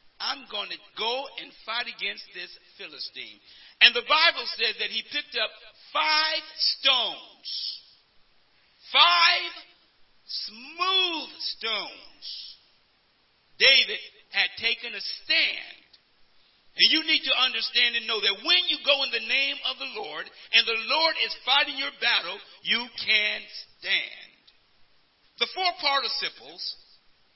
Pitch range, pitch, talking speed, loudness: 235-320 Hz, 285 Hz, 125 wpm, -23 LUFS